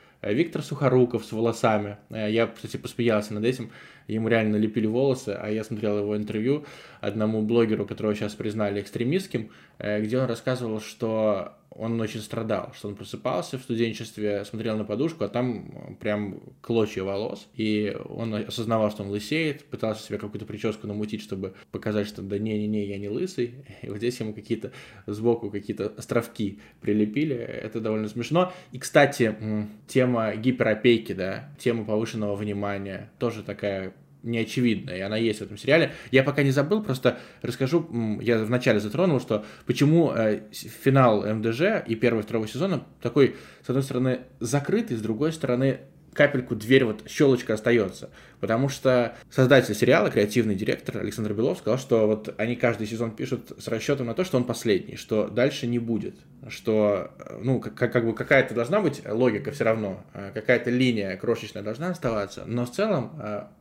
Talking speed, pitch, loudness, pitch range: 160 wpm, 115 Hz, -26 LUFS, 105-125 Hz